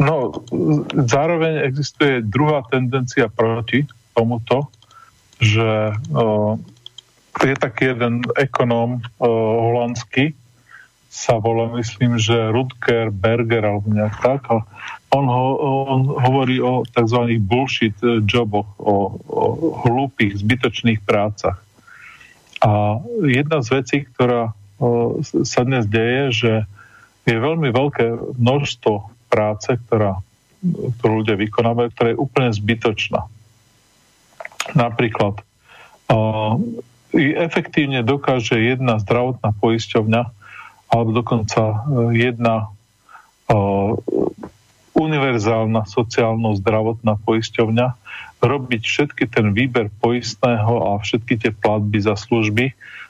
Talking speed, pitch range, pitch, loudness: 95 wpm, 110-130 Hz, 120 Hz, -18 LUFS